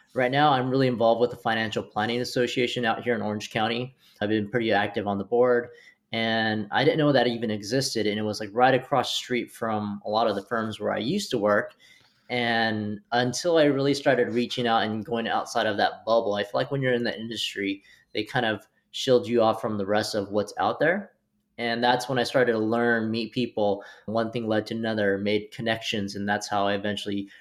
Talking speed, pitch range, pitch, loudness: 225 wpm, 105-120 Hz, 115 Hz, -25 LUFS